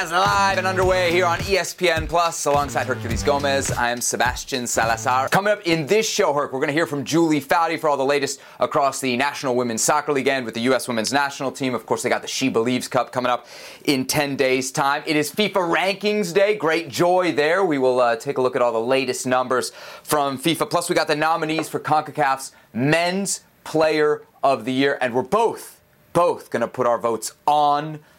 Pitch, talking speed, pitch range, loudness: 145 Hz, 215 wpm, 130-165 Hz, -21 LUFS